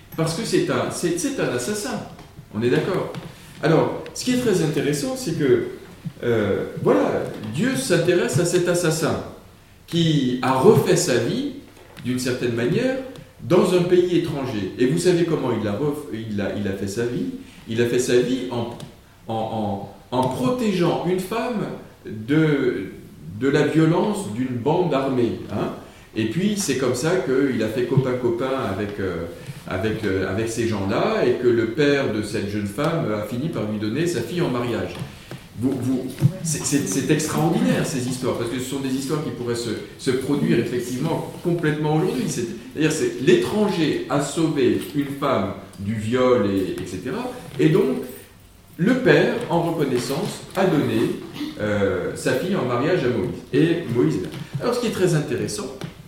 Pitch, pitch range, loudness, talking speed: 135 Hz, 115-170 Hz, -22 LUFS, 175 wpm